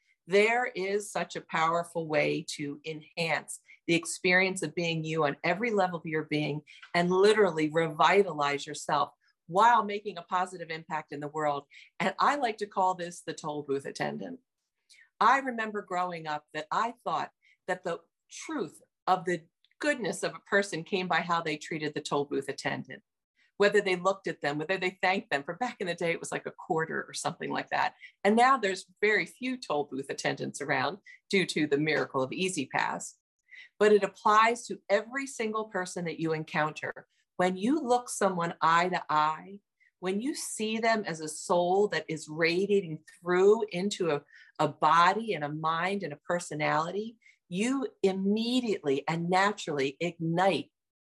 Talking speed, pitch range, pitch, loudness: 175 wpm, 155-200 Hz, 180 Hz, -29 LUFS